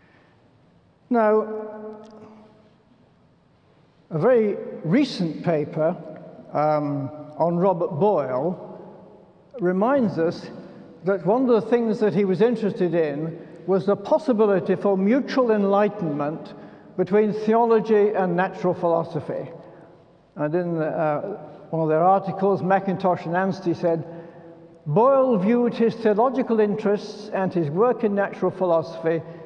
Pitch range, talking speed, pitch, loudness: 165-215 Hz, 110 wpm, 190 Hz, -22 LUFS